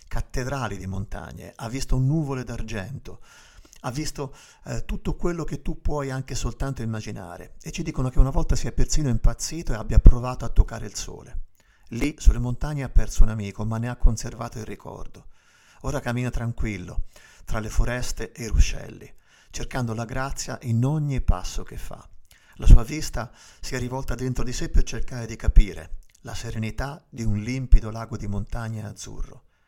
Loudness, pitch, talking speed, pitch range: -27 LUFS, 120 Hz, 175 wpm, 110-135 Hz